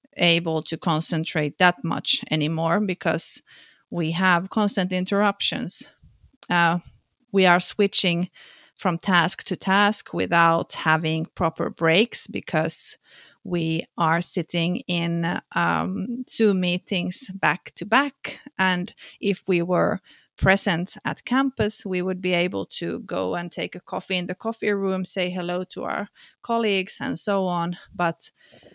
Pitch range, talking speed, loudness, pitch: 170-200 Hz, 135 wpm, -23 LUFS, 180 Hz